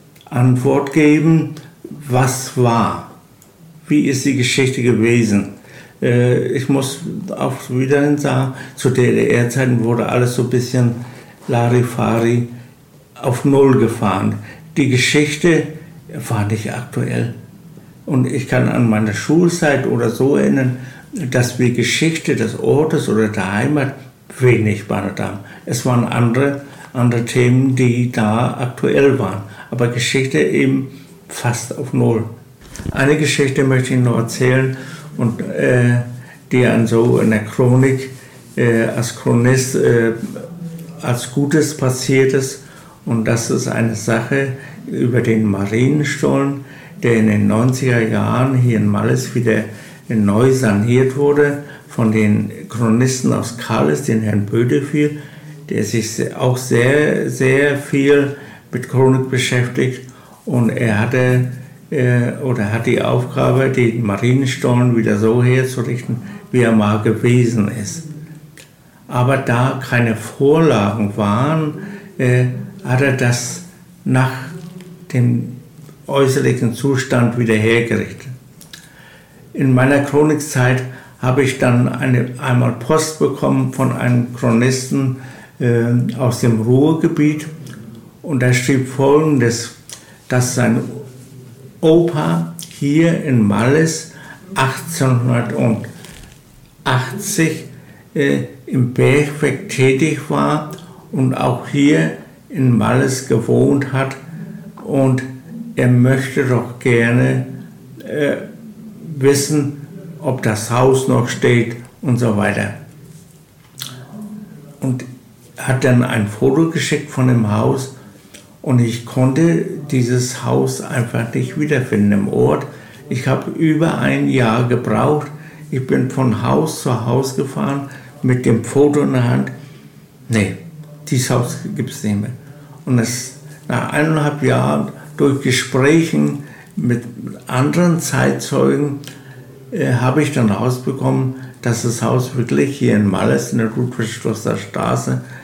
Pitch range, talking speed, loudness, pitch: 120-145 Hz, 115 wpm, -16 LUFS, 130 Hz